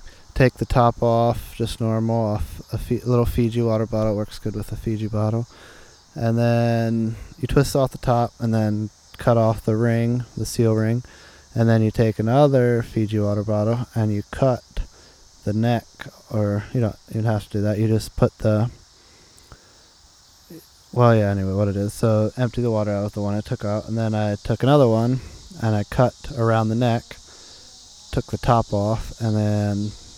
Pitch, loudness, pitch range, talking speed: 110 Hz, -22 LUFS, 105-120 Hz, 190 wpm